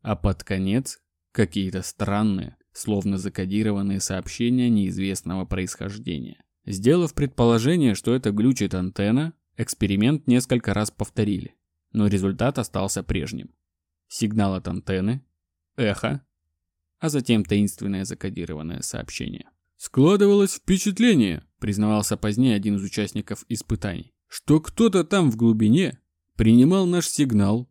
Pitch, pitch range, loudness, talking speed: 105 Hz, 95-120 Hz, -23 LUFS, 105 wpm